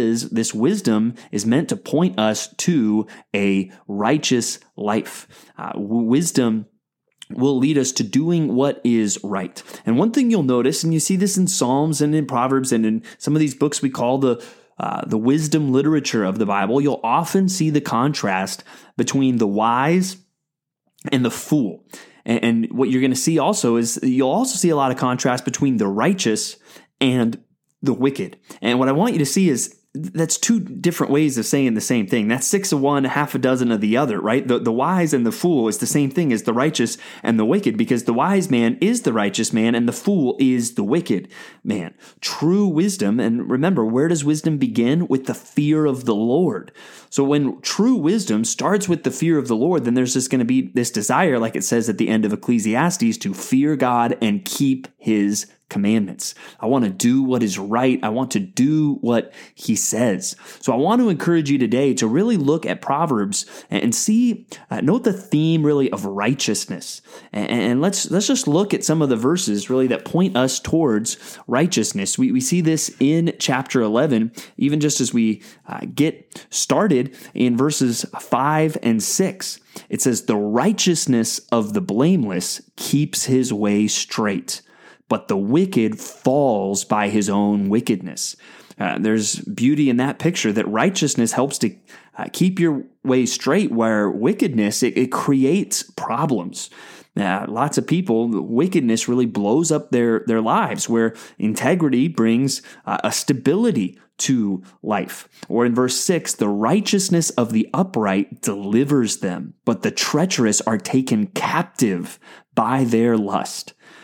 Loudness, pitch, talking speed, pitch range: -19 LUFS, 130 Hz, 180 wpm, 115-160 Hz